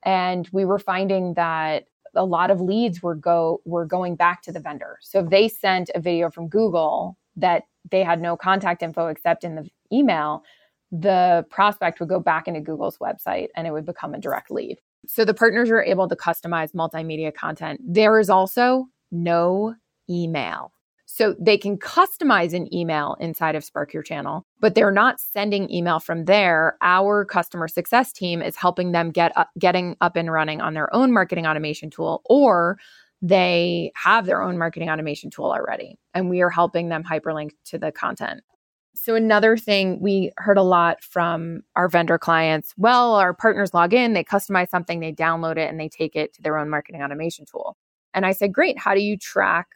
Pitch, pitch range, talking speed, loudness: 175 Hz, 165-200 Hz, 190 wpm, -21 LUFS